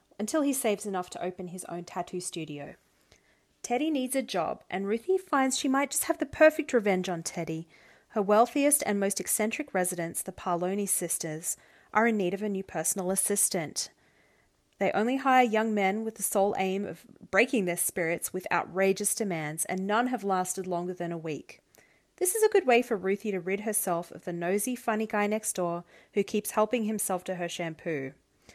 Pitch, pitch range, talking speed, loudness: 195 Hz, 180-225 Hz, 190 wpm, -29 LUFS